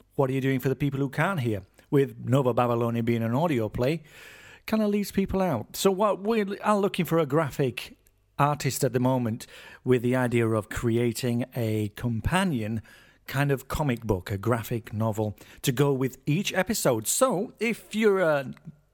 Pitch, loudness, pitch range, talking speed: 135 Hz, -26 LUFS, 115-170 Hz, 180 wpm